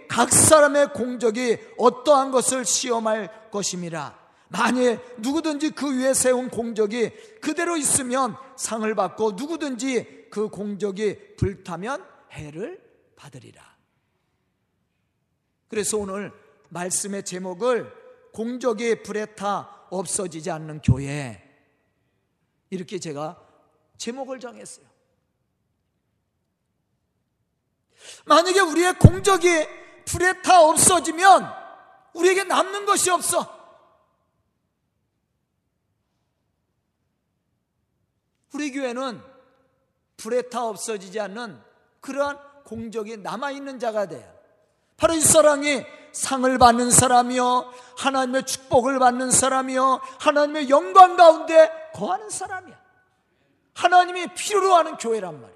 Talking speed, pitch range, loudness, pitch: 225 characters per minute, 215-310 Hz, -20 LUFS, 255 Hz